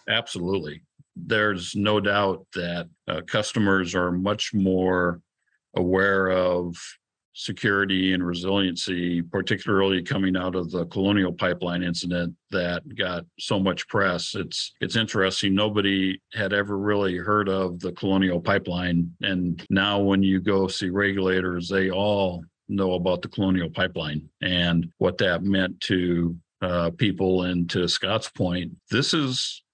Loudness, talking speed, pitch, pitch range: -24 LUFS, 135 wpm, 95 Hz, 90-100 Hz